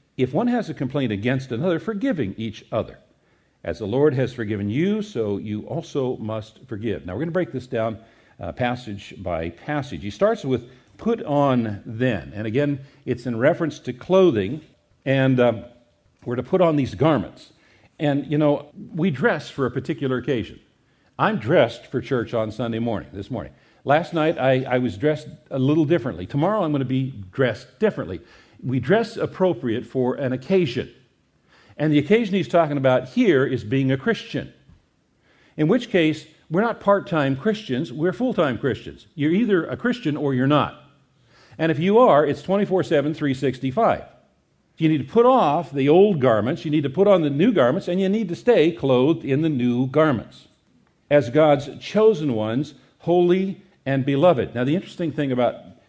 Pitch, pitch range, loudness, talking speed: 140 Hz, 125-170 Hz, -22 LUFS, 180 wpm